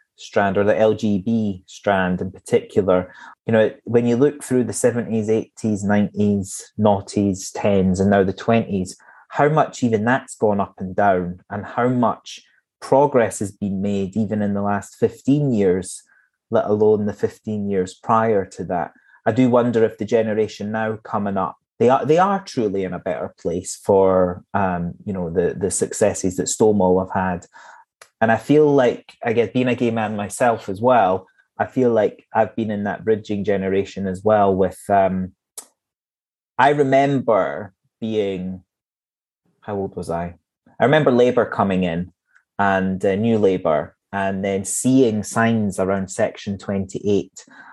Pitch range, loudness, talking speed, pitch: 95-110 Hz, -20 LUFS, 165 wpm, 100 Hz